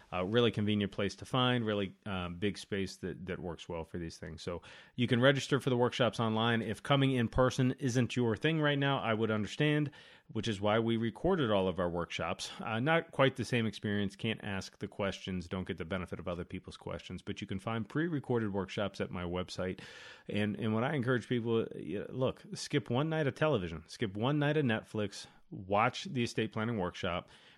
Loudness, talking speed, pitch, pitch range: -34 LUFS, 205 wpm, 110 Hz, 95-125 Hz